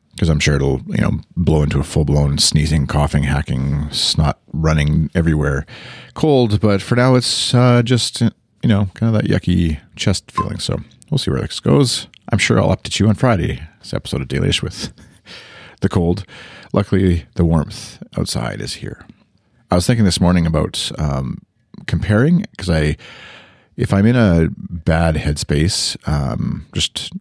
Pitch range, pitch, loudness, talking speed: 75-105 Hz, 85 Hz, -17 LUFS, 170 wpm